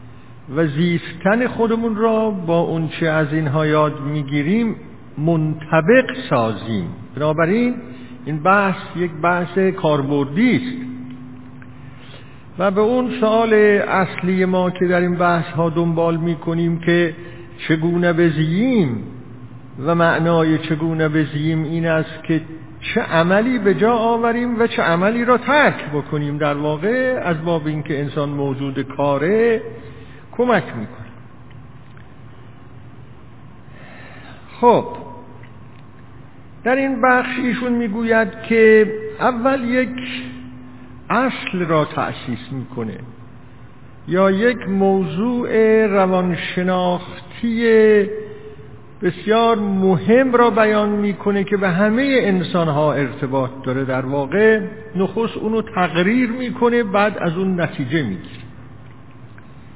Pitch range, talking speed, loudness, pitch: 135-215 Hz, 105 wpm, -18 LUFS, 170 Hz